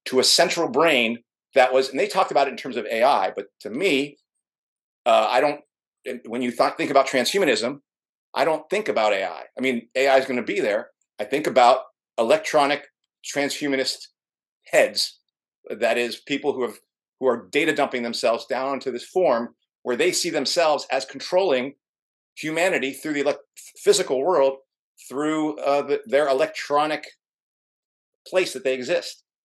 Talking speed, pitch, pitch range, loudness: 165 wpm, 140 Hz, 130-155 Hz, -22 LUFS